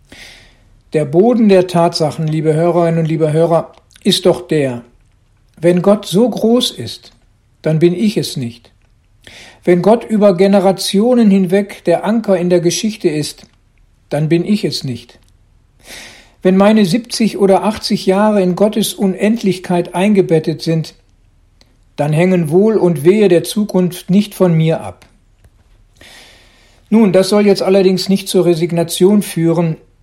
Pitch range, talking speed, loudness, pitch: 125-195 Hz, 140 wpm, -13 LUFS, 175 Hz